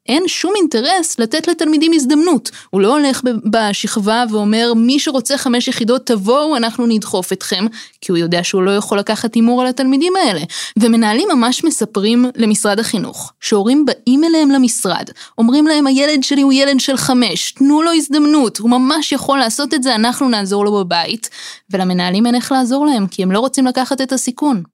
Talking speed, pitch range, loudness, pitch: 175 wpm, 220-280 Hz, -14 LUFS, 245 Hz